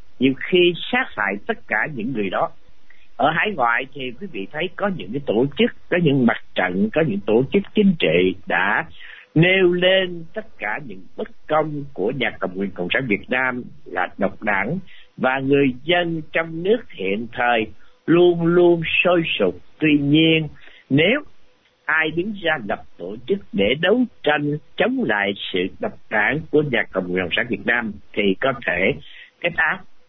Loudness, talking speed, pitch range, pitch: -20 LUFS, 180 wpm, 120-180 Hz, 155 Hz